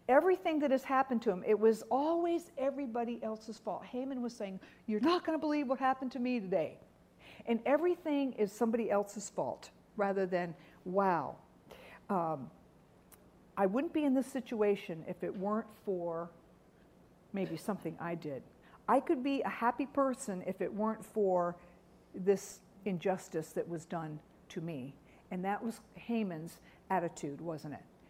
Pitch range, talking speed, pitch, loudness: 180-255 Hz, 155 wpm, 210 Hz, -35 LUFS